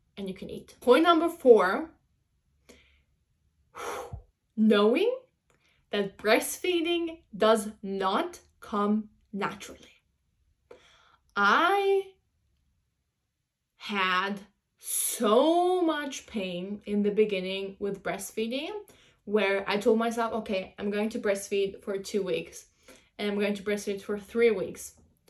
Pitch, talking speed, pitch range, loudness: 215 Hz, 105 wpm, 200-270 Hz, -27 LUFS